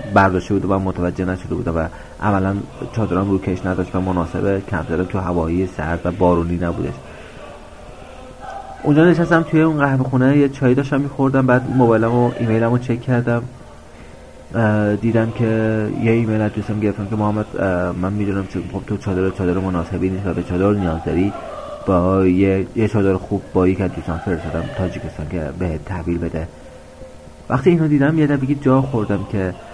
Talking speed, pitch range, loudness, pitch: 165 wpm, 90-115 Hz, -18 LUFS, 95 Hz